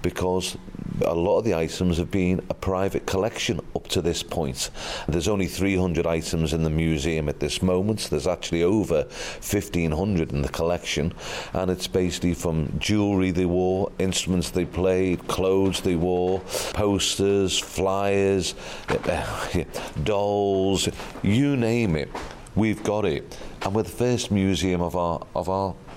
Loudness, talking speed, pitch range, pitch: -24 LUFS, 150 wpm, 85-95 Hz, 90 Hz